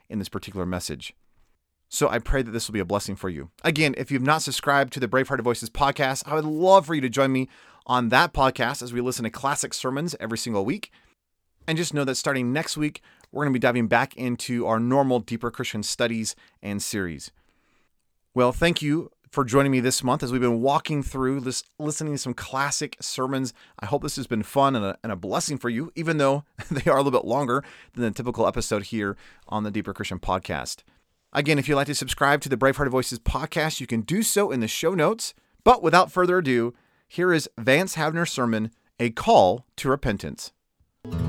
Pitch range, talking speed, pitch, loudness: 115-145 Hz, 215 wpm, 130 Hz, -24 LUFS